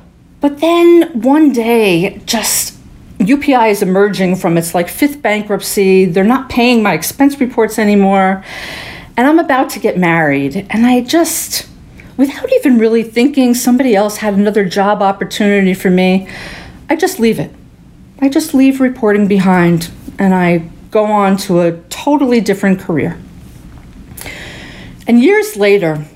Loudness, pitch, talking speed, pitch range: -11 LUFS, 210 Hz, 140 wpm, 190-255 Hz